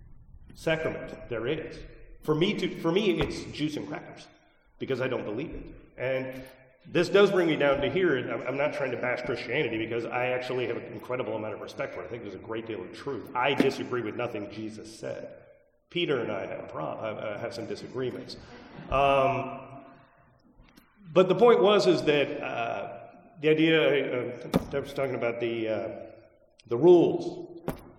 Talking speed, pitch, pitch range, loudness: 180 wpm, 140 Hz, 125-165 Hz, -28 LUFS